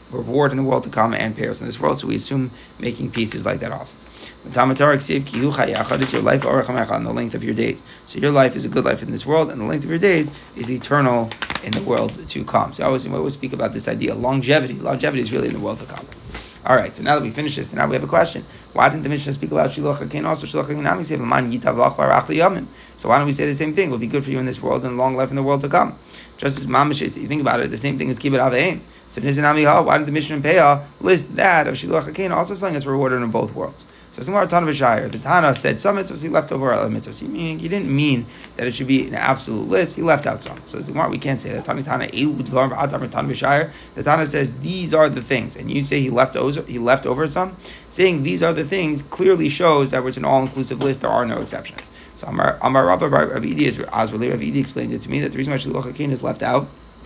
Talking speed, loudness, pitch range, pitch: 250 wpm, -19 LUFS, 130-150 Hz, 135 Hz